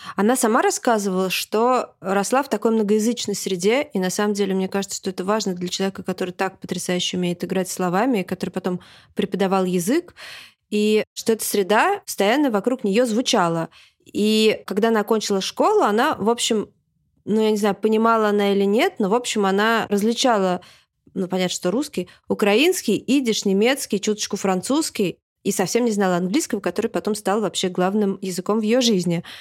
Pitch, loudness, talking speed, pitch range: 205 Hz, -21 LUFS, 165 wpm, 190-225 Hz